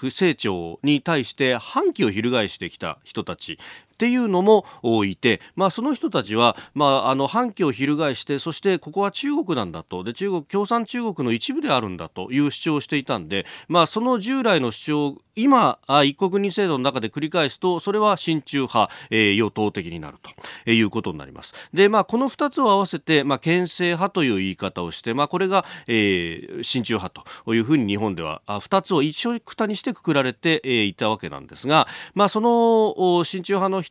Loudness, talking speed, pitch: -21 LUFS, 380 characters per minute, 155 Hz